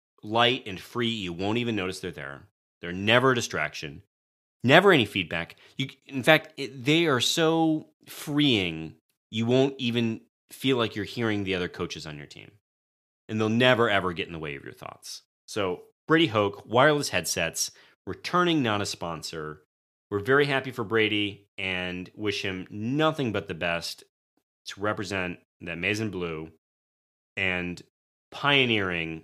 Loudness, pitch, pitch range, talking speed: -26 LUFS, 100 Hz, 85-125 Hz, 155 wpm